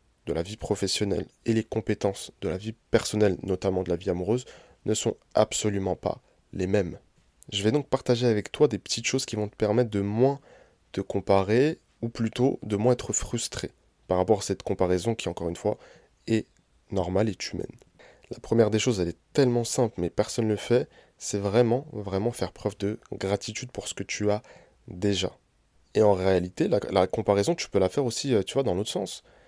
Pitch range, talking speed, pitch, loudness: 95-115 Hz, 205 wpm, 105 Hz, -27 LUFS